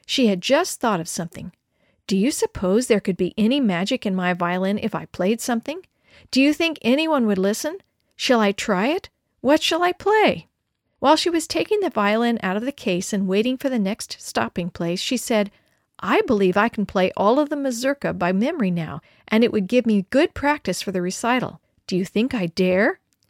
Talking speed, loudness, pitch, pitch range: 210 wpm, -21 LUFS, 220 Hz, 190-275 Hz